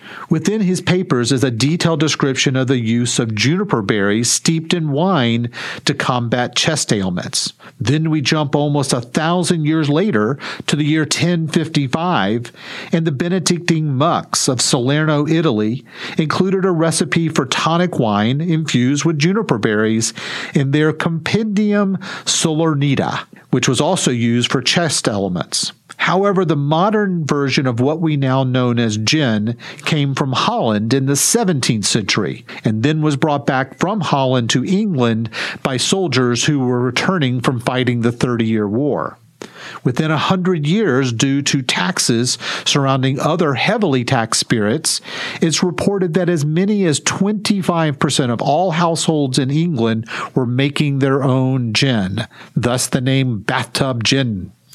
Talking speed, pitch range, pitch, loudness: 145 wpm, 125-170 Hz, 145 Hz, -16 LUFS